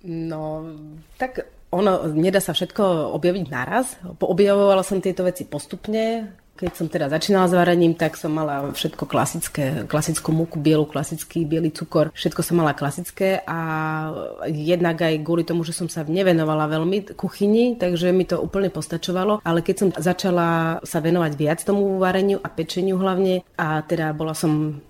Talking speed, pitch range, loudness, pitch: 160 wpm, 155-190 Hz, -22 LUFS, 170 Hz